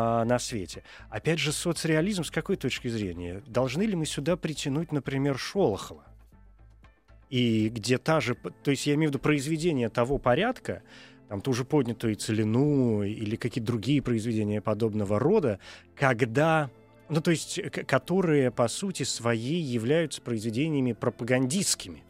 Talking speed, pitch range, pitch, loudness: 140 wpm, 110-150 Hz, 125 Hz, -28 LUFS